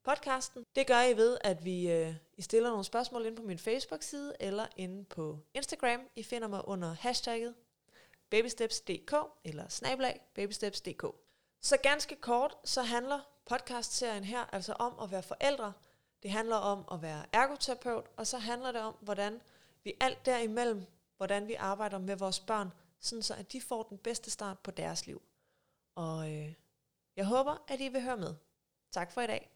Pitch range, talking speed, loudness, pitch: 195-245 Hz, 170 wpm, -35 LUFS, 225 Hz